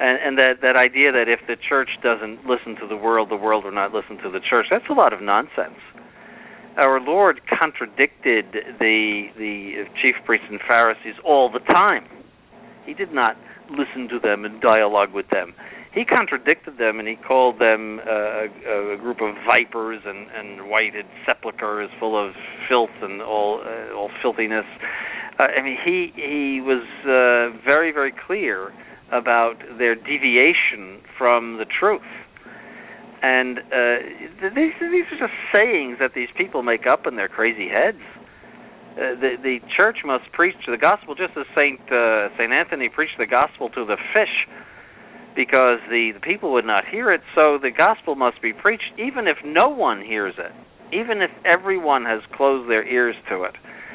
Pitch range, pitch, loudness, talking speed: 110-130 Hz, 120 Hz, -20 LUFS, 170 wpm